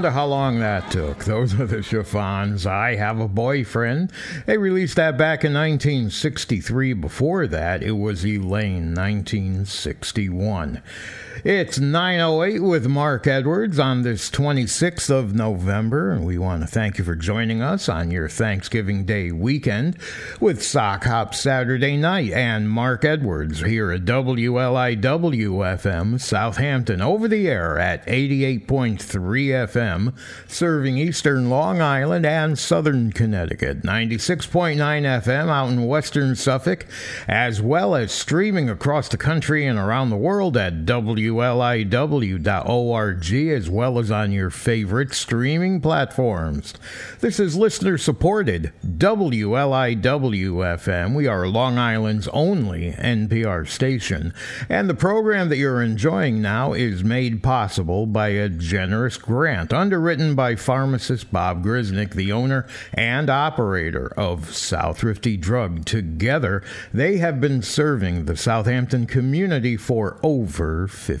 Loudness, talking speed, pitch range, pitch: -21 LUFS, 125 wpm, 105-140 Hz, 120 Hz